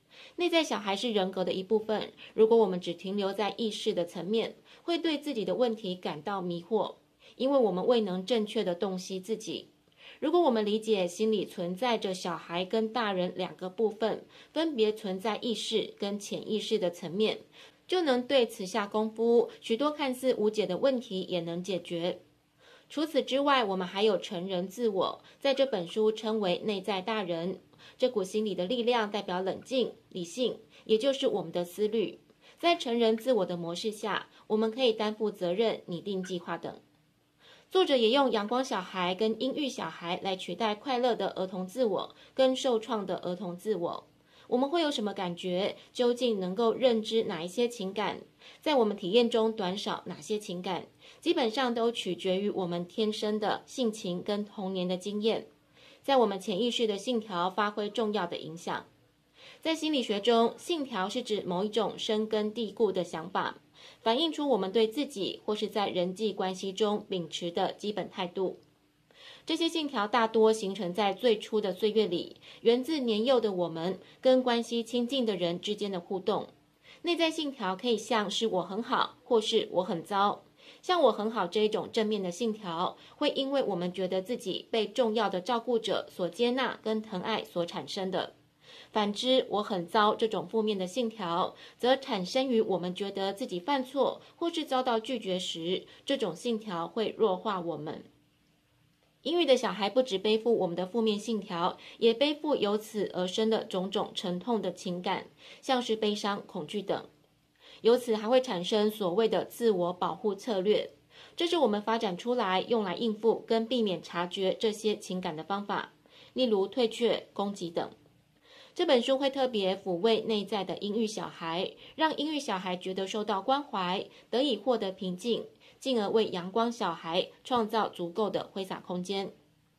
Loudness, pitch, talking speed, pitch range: -30 LUFS, 215 Hz, 260 characters per minute, 185-240 Hz